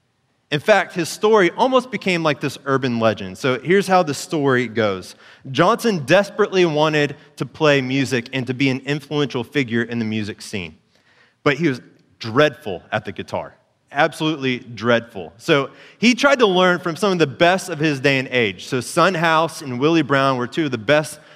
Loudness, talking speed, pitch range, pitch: -19 LUFS, 190 wpm, 130-170 Hz, 150 Hz